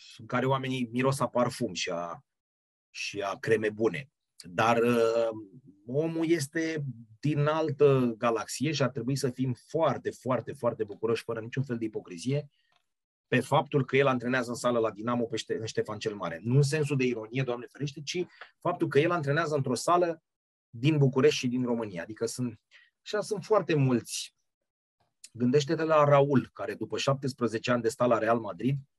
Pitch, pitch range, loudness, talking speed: 130 Hz, 115-145 Hz, -29 LUFS, 175 wpm